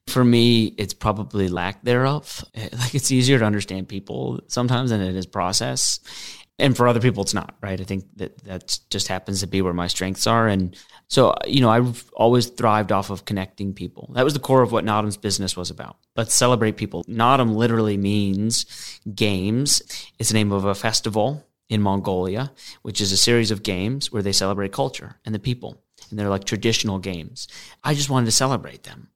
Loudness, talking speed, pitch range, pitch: -21 LUFS, 200 wpm, 95-120 Hz, 105 Hz